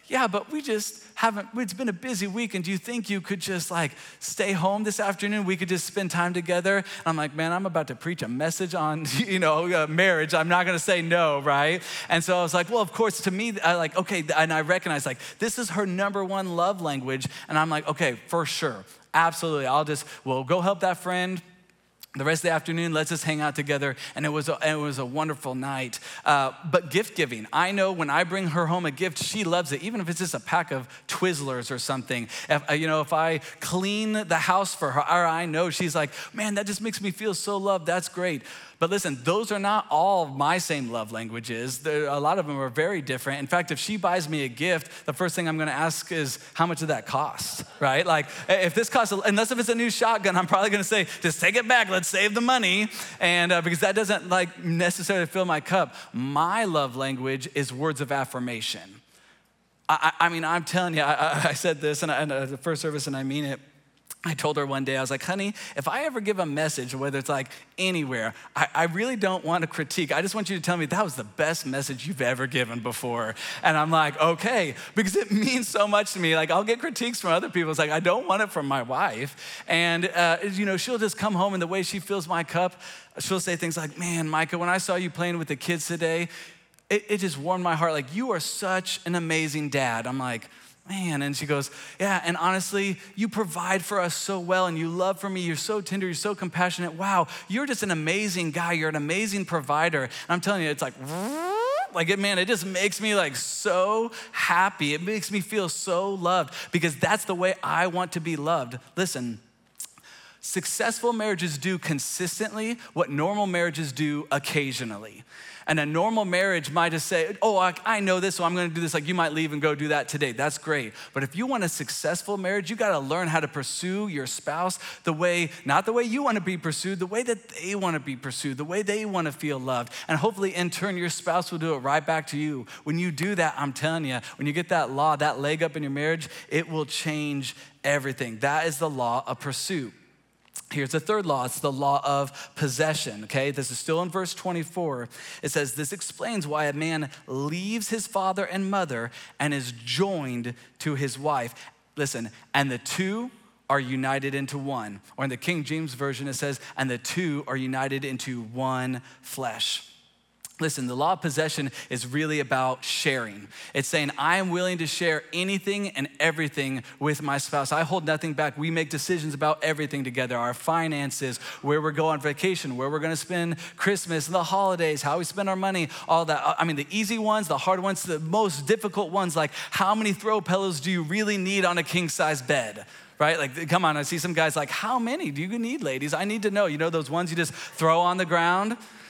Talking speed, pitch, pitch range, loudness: 225 wpm, 170 Hz, 145-190 Hz, -26 LUFS